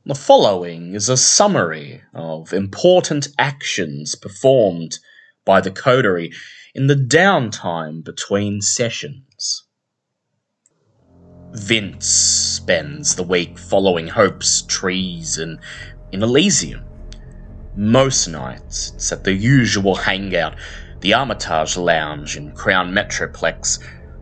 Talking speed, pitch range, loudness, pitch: 100 wpm, 80-120 Hz, -17 LUFS, 95 Hz